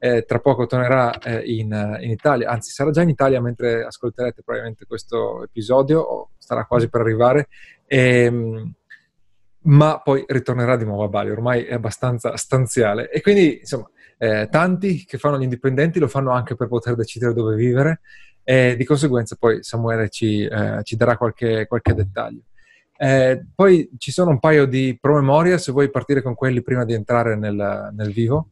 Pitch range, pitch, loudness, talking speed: 115-140 Hz, 125 Hz, -19 LUFS, 180 wpm